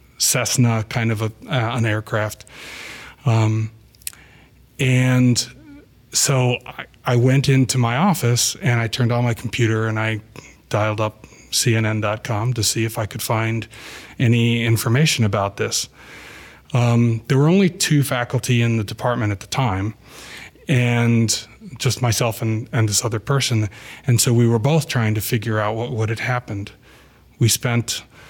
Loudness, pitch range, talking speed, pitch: -19 LUFS, 110-125 Hz, 155 wpm, 120 Hz